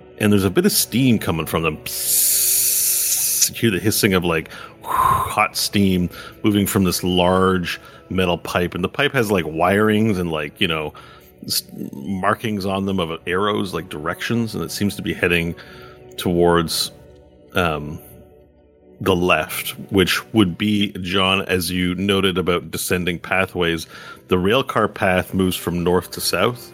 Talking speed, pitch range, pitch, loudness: 155 wpm, 80-100 Hz, 90 Hz, -19 LUFS